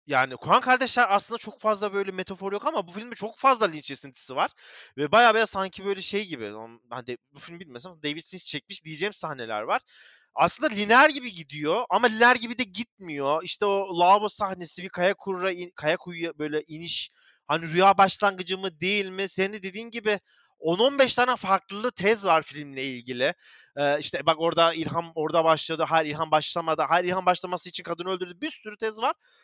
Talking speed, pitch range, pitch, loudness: 190 wpm, 160-210 Hz, 185 Hz, -25 LUFS